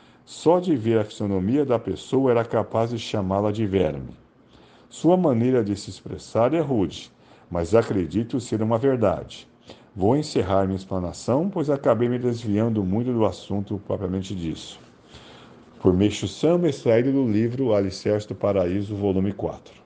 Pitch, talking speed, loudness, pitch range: 110 Hz, 150 wpm, -23 LUFS, 100-120 Hz